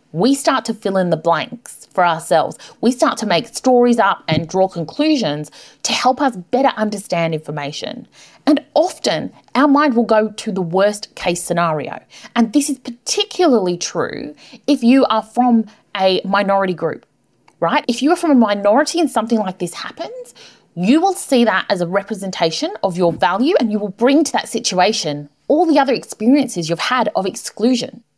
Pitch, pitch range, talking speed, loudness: 220 Hz, 180-265 Hz, 180 wpm, -17 LUFS